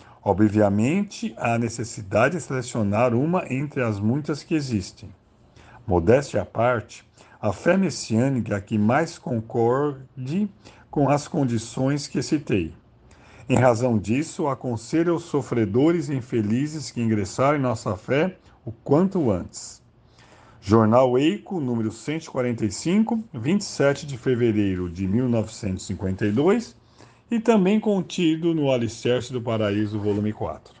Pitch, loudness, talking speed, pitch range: 125 Hz, -23 LUFS, 115 wpm, 110-150 Hz